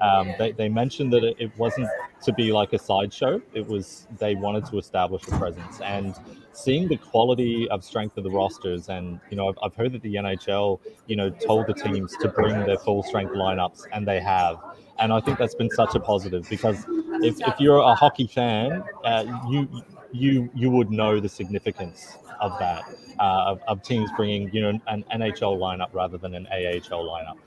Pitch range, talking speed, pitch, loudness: 95-120 Hz, 200 wpm, 110 Hz, -24 LUFS